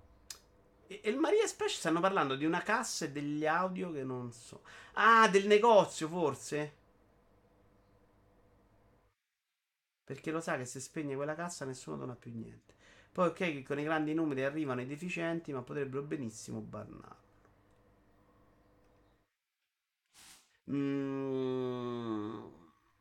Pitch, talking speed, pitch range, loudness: 135 Hz, 120 wpm, 100-160 Hz, -33 LUFS